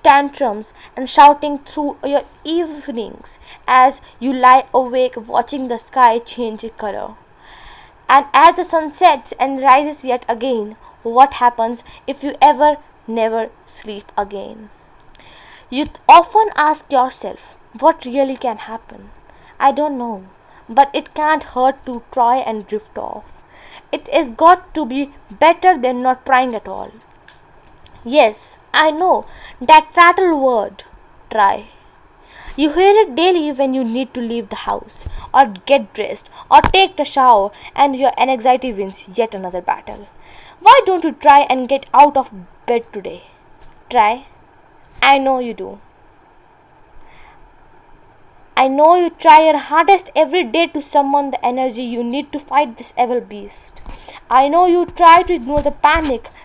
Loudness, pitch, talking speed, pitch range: -14 LUFS, 275 Hz, 145 wpm, 245-310 Hz